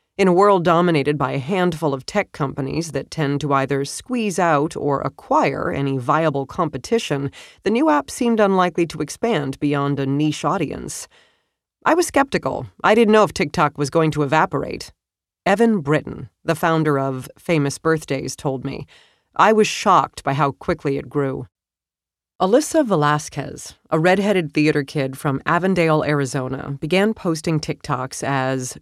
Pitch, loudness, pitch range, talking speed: 150 Hz, -19 LUFS, 140-180 Hz, 155 wpm